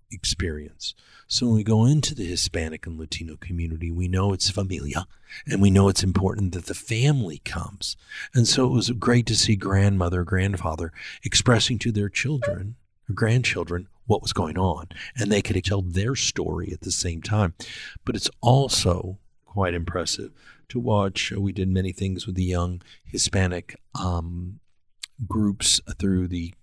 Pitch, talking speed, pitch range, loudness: 95 Hz, 160 wpm, 90-110 Hz, -24 LUFS